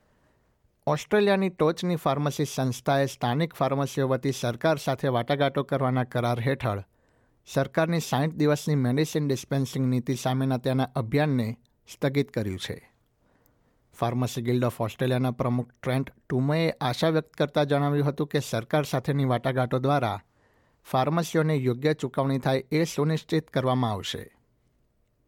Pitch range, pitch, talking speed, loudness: 125-150 Hz, 135 Hz, 120 wpm, -27 LUFS